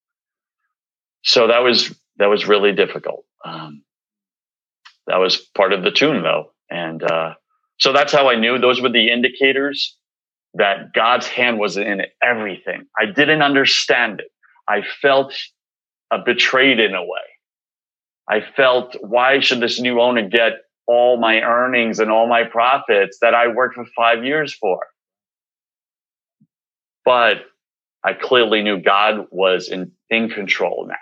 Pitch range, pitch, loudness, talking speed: 110-135 Hz, 120 Hz, -16 LUFS, 145 wpm